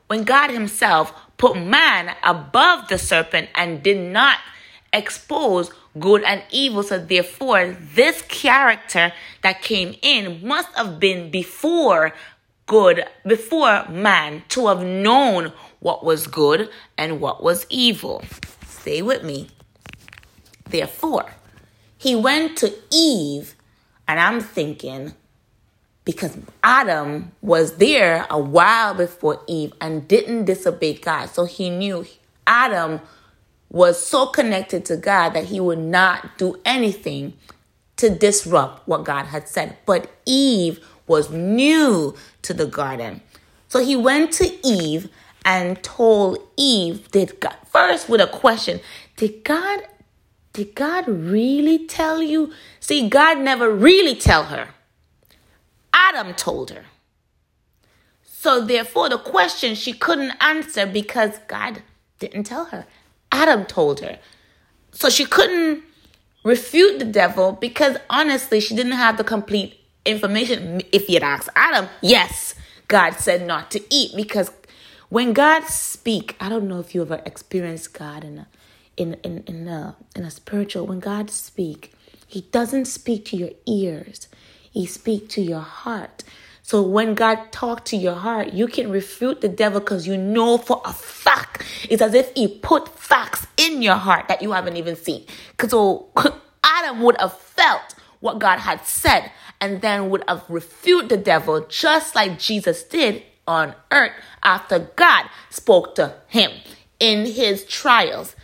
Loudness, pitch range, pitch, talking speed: -18 LUFS, 180-255 Hz, 210 Hz, 140 wpm